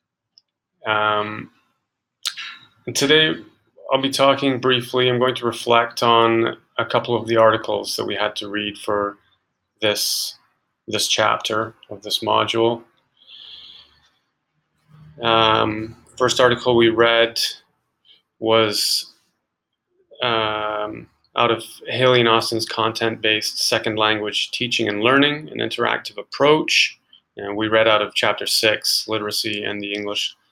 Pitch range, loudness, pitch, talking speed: 105-120 Hz, -19 LUFS, 115 Hz, 120 wpm